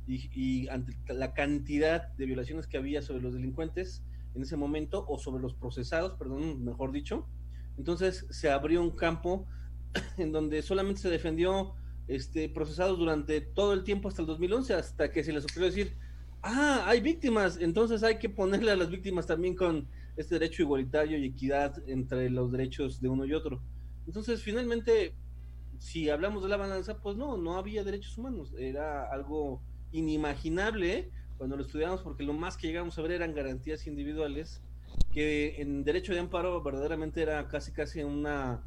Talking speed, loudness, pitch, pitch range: 170 wpm, -33 LUFS, 155 Hz, 130-180 Hz